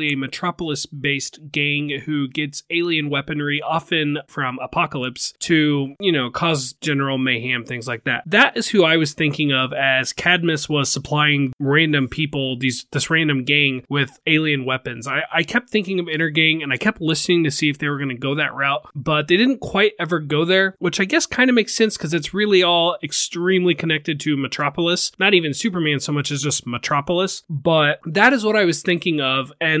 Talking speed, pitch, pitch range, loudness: 200 wpm, 150 Hz, 140-175 Hz, -19 LUFS